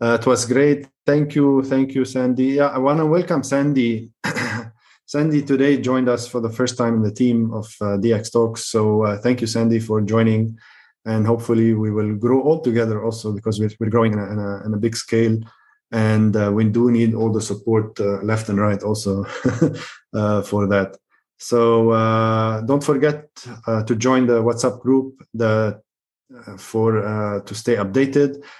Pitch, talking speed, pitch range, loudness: 115 Hz, 185 wpm, 110-130 Hz, -19 LUFS